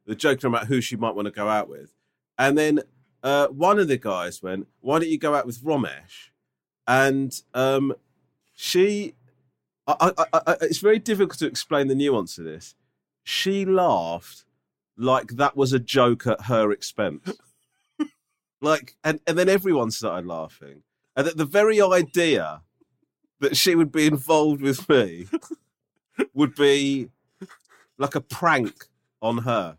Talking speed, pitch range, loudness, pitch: 155 wpm, 120-165 Hz, -22 LUFS, 140 Hz